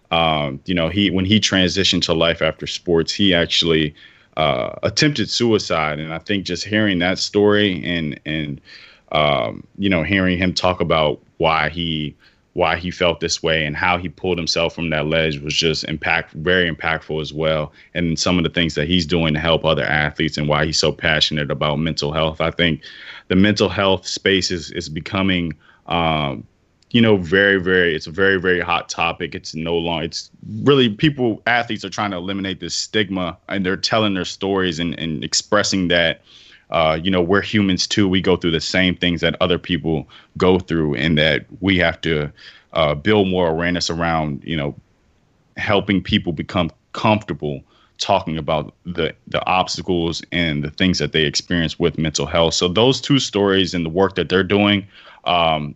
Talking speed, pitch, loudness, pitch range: 185 wpm, 85 Hz, -18 LUFS, 80-95 Hz